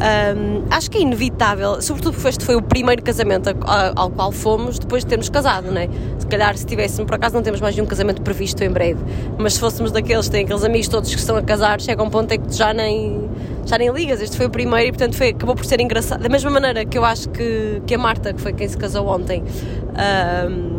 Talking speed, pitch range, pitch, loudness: 245 wpm, 105-115 Hz, 110 Hz, -18 LUFS